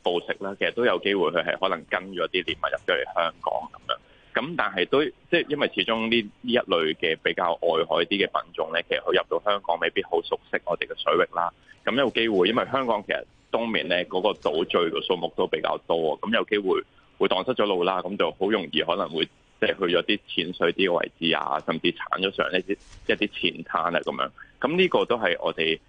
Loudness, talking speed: -25 LUFS, 330 characters per minute